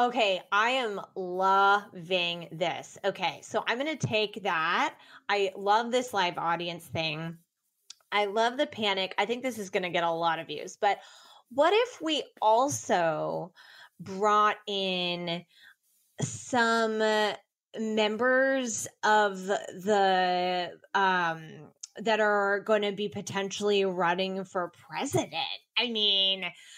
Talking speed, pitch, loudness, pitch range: 125 wpm, 200 Hz, -28 LUFS, 180-220 Hz